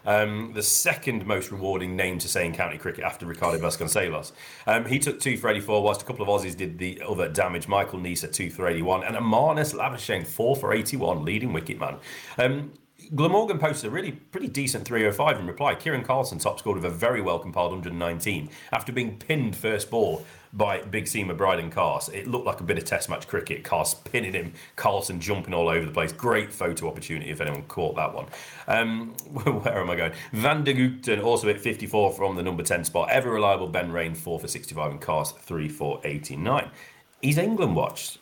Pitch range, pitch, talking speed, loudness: 90-125 Hz, 105 Hz, 205 wpm, -26 LUFS